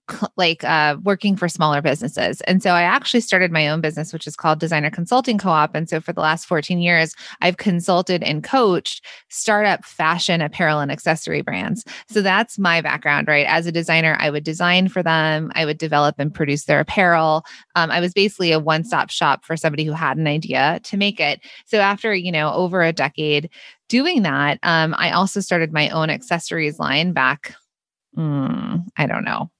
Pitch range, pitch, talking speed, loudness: 155-180 Hz, 165 Hz, 195 wpm, -18 LUFS